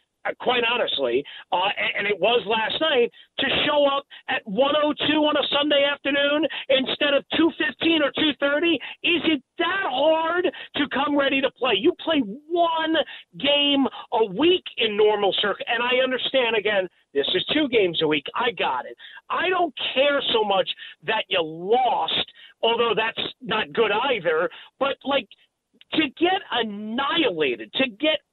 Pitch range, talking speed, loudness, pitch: 240-320 Hz, 155 wpm, -22 LUFS, 285 Hz